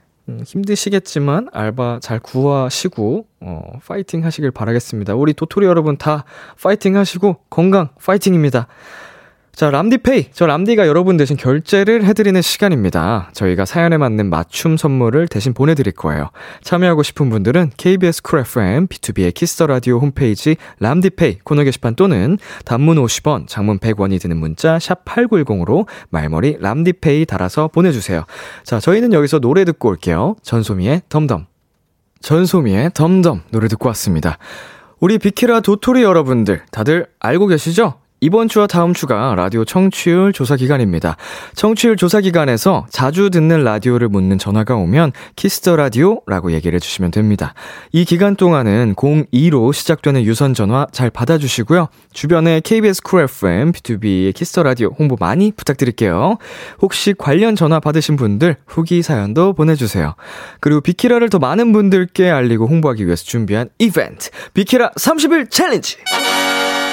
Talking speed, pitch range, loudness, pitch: 350 characters per minute, 115-180 Hz, -14 LUFS, 150 Hz